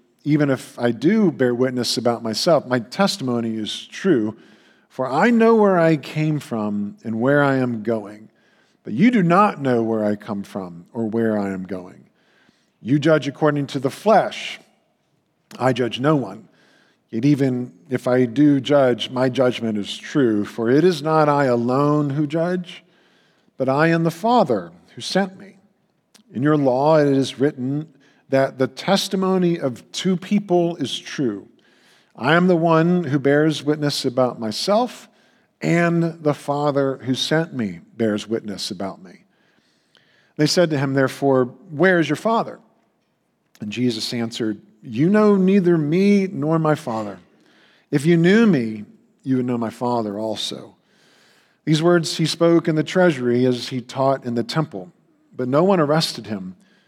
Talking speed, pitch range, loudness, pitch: 160 wpm, 120-170 Hz, -19 LUFS, 140 Hz